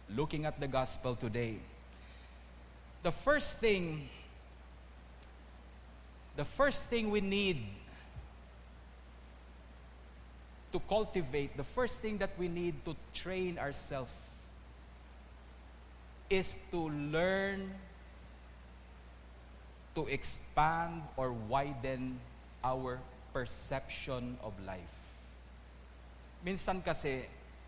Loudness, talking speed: -37 LUFS, 80 wpm